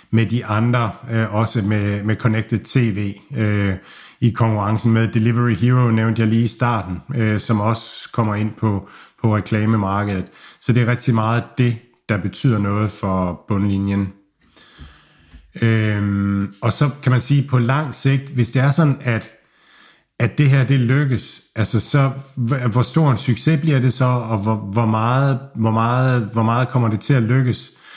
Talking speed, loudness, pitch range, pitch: 170 wpm, -19 LUFS, 105-125 Hz, 115 Hz